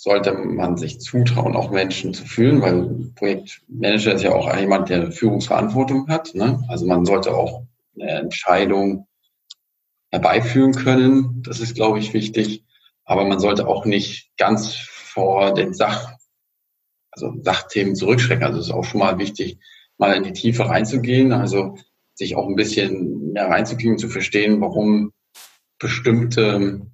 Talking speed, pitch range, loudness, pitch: 145 wpm, 100-120 Hz, -19 LUFS, 110 Hz